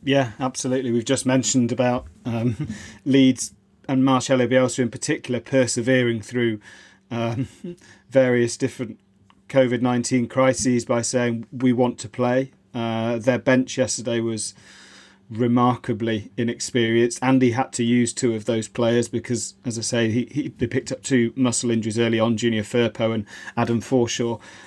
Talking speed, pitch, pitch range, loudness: 150 wpm, 120 Hz, 115-130 Hz, -22 LUFS